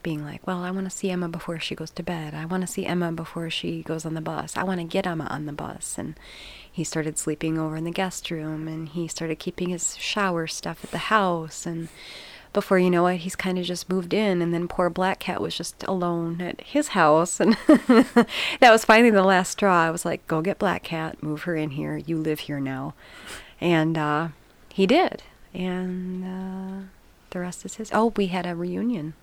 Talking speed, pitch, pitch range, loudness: 225 wpm, 175 Hz, 160-190 Hz, -24 LUFS